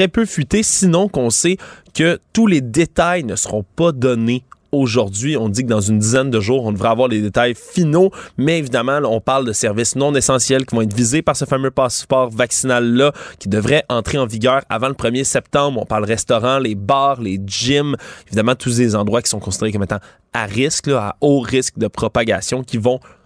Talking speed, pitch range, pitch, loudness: 210 wpm, 110-140 Hz, 130 Hz, -16 LUFS